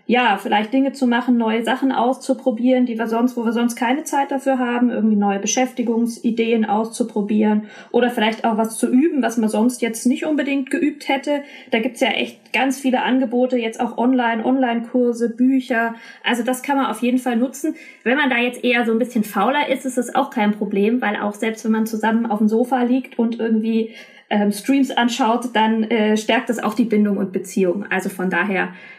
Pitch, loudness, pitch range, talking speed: 240 Hz, -19 LUFS, 220-255 Hz, 205 wpm